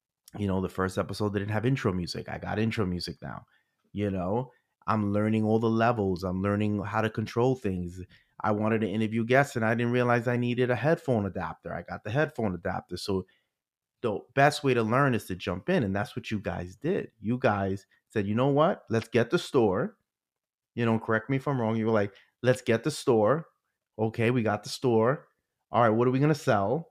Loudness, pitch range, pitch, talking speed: -28 LUFS, 100-125 Hz, 110 Hz, 220 wpm